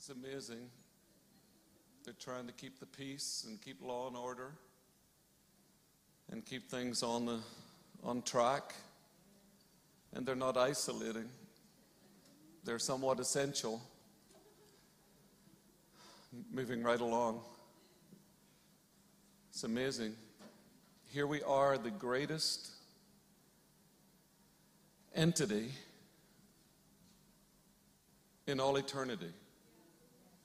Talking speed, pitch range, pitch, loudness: 80 wpm, 120-145 Hz, 130 Hz, -39 LUFS